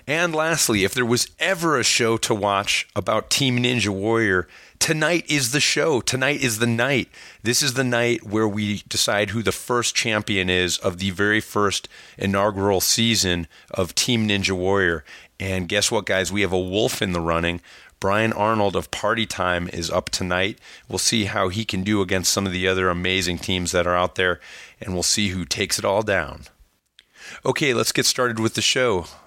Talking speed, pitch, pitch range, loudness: 195 wpm, 105 Hz, 95-120 Hz, -21 LUFS